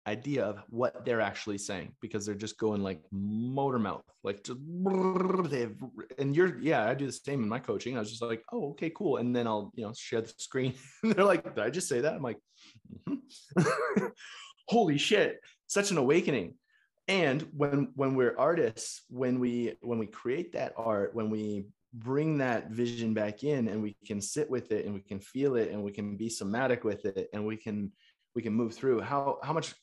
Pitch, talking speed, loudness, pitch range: 120 Hz, 205 wpm, -32 LUFS, 110-145 Hz